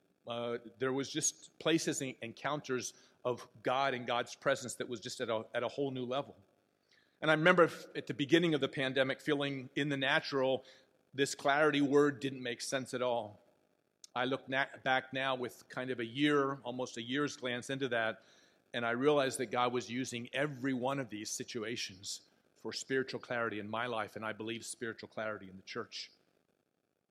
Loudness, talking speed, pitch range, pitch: -35 LUFS, 190 wpm, 120-140 Hz, 130 Hz